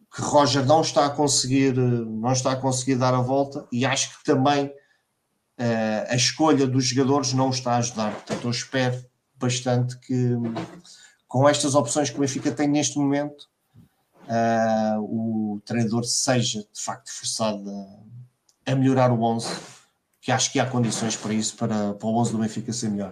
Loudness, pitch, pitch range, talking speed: -23 LUFS, 125 Hz, 115-140 Hz, 175 wpm